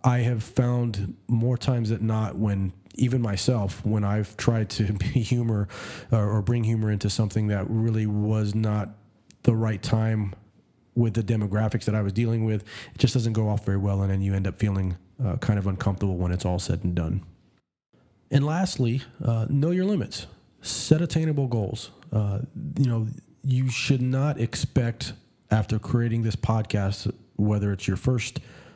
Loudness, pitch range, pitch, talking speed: -26 LUFS, 105-125 Hz, 110 Hz, 175 wpm